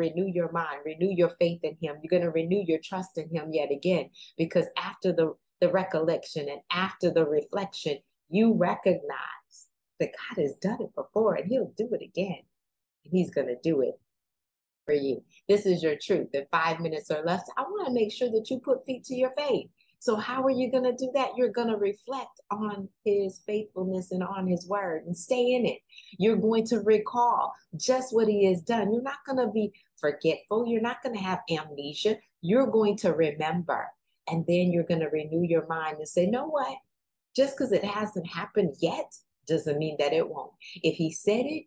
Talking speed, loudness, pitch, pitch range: 210 wpm, -28 LUFS, 190 Hz, 165-225 Hz